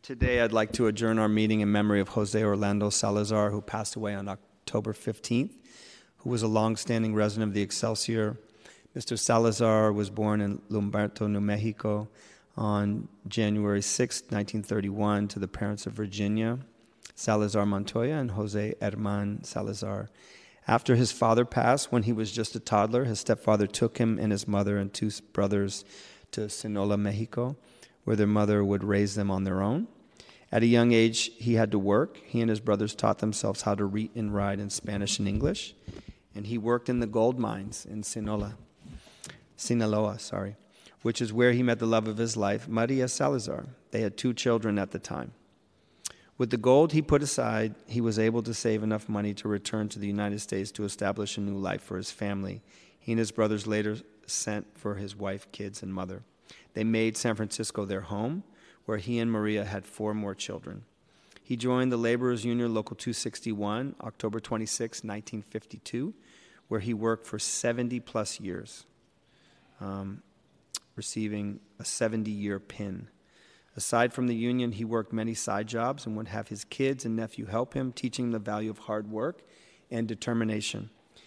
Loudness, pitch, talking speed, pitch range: -29 LUFS, 110 Hz, 175 wpm, 105-115 Hz